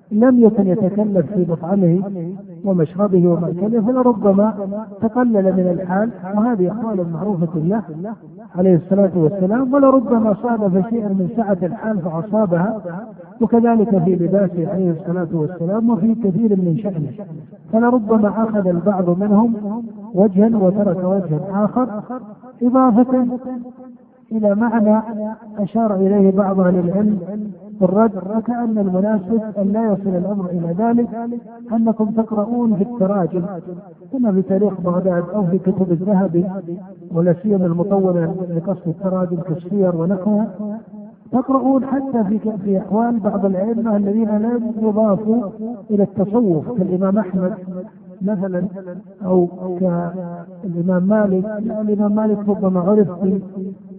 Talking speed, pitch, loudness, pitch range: 115 wpm, 200 Hz, -17 LUFS, 185-220 Hz